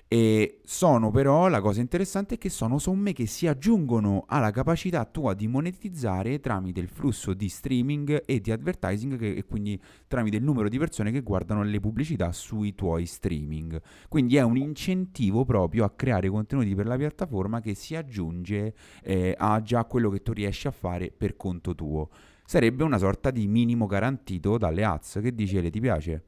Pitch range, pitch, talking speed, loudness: 95-135 Hz, 110 Hz, 185 wpm, -27 LUFS